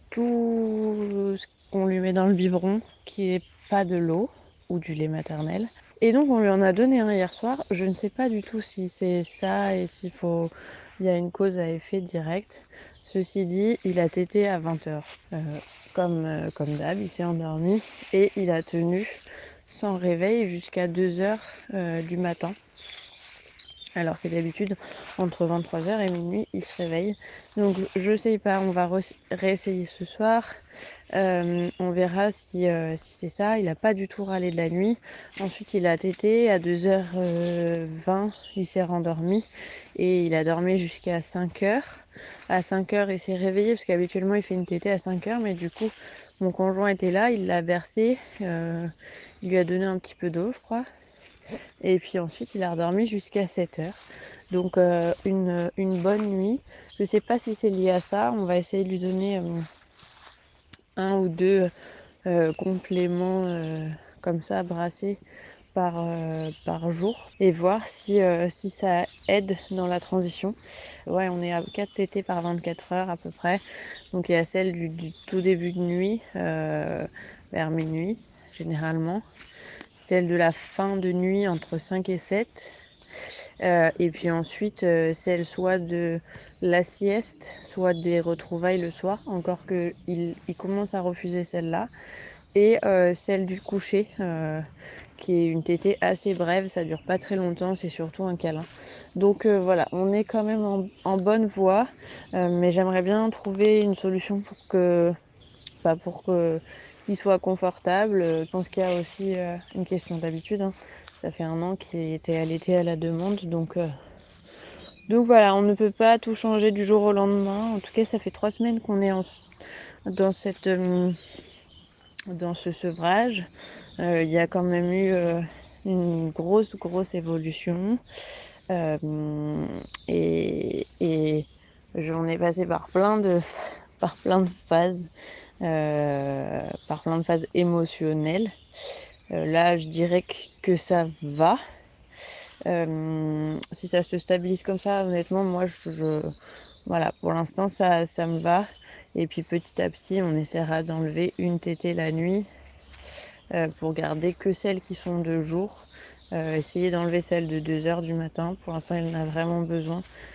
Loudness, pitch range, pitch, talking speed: -26 LUFS, 170-195 Hz, 180 Hz, 175 wpm